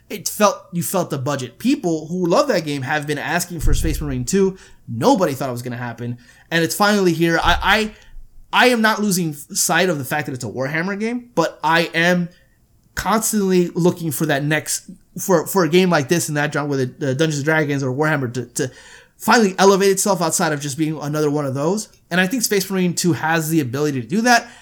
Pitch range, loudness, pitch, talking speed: 145-190 Hz, -19 LUFS, 165 Hz, 225 wpm